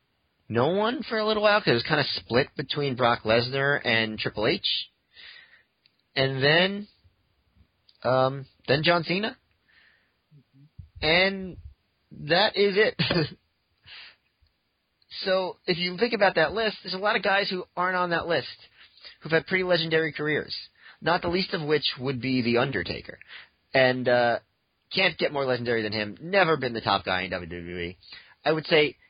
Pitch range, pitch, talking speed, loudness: 120-180 Hz, 145 Hz, 160 wpm, -25 LUFS